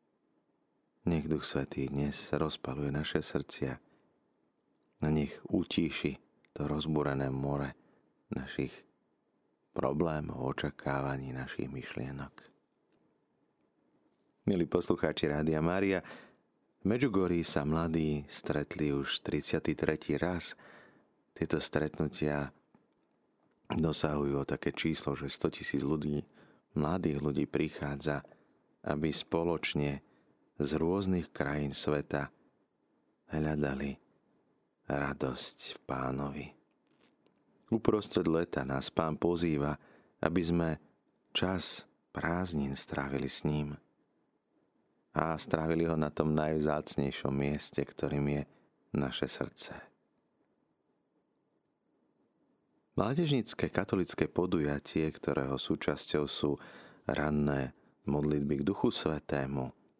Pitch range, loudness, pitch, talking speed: 70-80 Hz, -34 LUFS, 75 Hz, 85 wpm